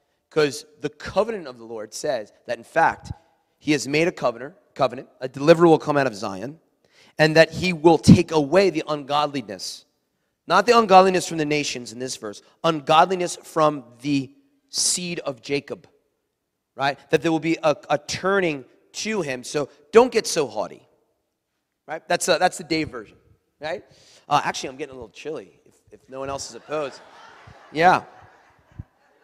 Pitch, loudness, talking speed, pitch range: 155 Hz, -21 LUFS, 170 wpm, 140-175 Hz